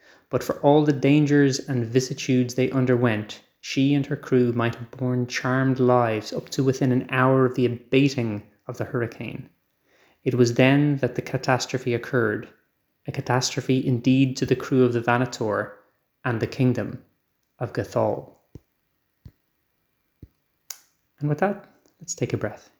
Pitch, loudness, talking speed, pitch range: 130 Hz, -23 LUFS, 150 wpm, 120-135 Hz